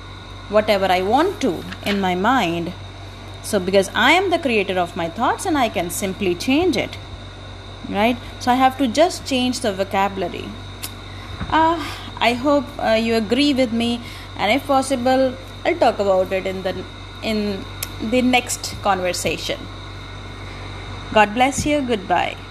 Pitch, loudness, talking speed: 195 Hz, -19 LUFS, 150 wpm